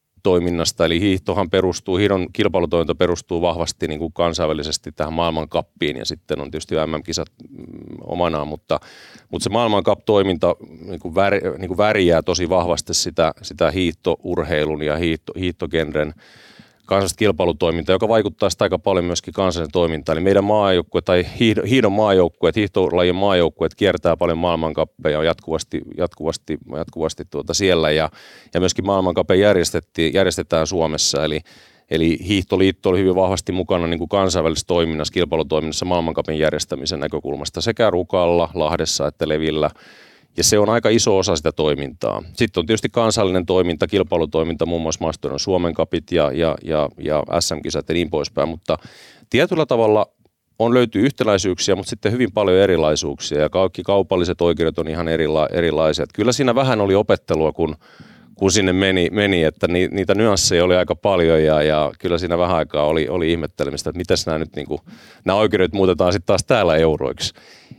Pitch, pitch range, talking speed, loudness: 85 Hz, 80-95 Hz, 150 wpm, -19 LUFS